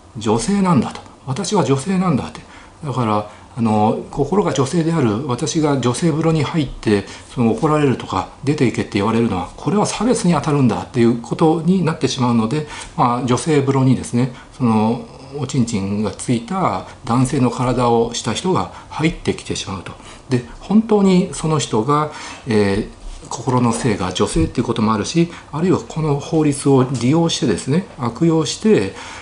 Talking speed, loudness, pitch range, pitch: 345 characters per minute, -18 LUFS, 115-160 Hz, 130 Hz